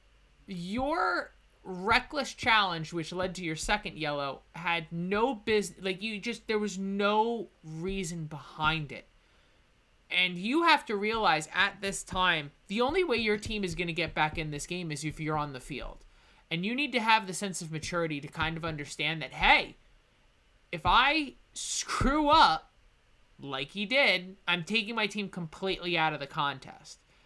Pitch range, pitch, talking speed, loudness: 160-215 Hz, 185 Hz, 175 wpm, -29 LUFS